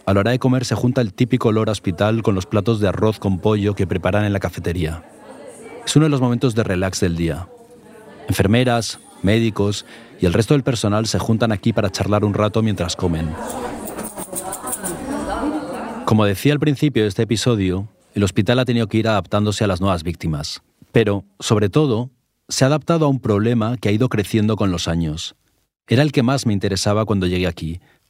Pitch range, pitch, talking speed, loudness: 95-120 Hz, 105 Hz, 195 wpm, -19 LUFS